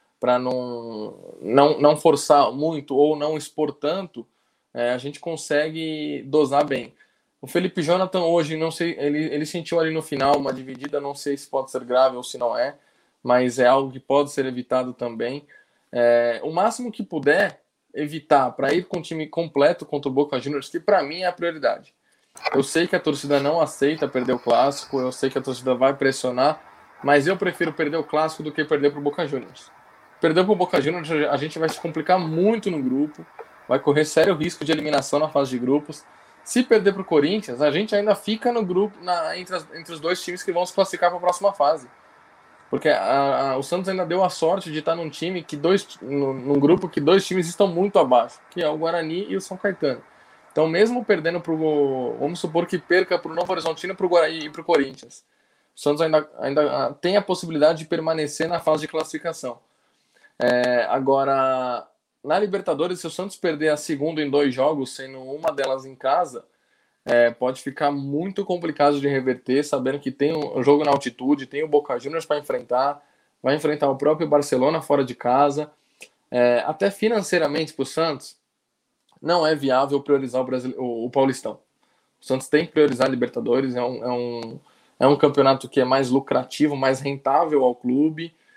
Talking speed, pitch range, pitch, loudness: 200 wpm, 135-170 Hz, 150 Hz, -22 LUFS